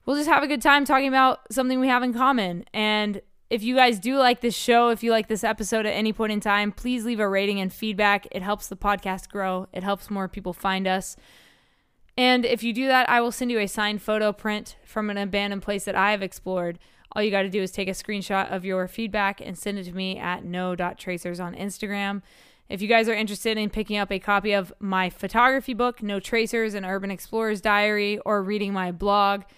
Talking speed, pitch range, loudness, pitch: 230 wpm, 195-230 Hz, -24 LUFS, 205 Hz